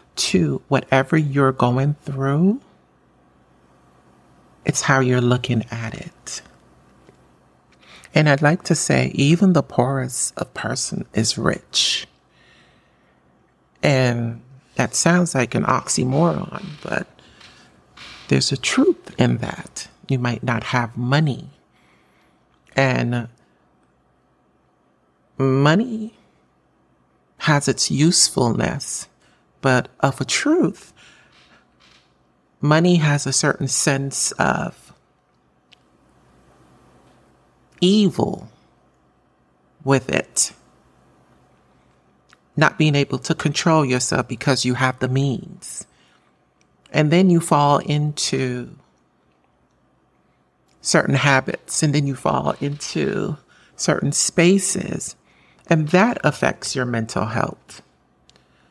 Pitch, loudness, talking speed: 125 Hz, -19 LUFS, 90 wpm